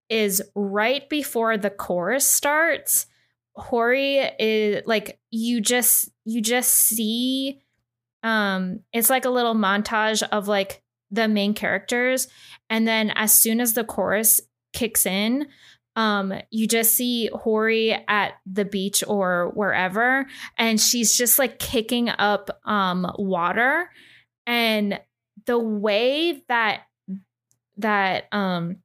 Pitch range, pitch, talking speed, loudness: 200-240 Hz, 220 Hz, 120 wpm, -21 LUFS